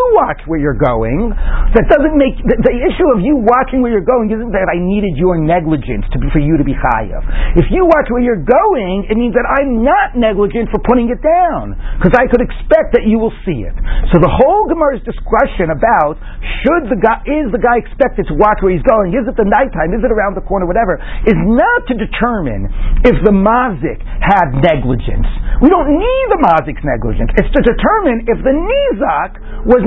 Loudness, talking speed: -13 LUFS, 210 wpm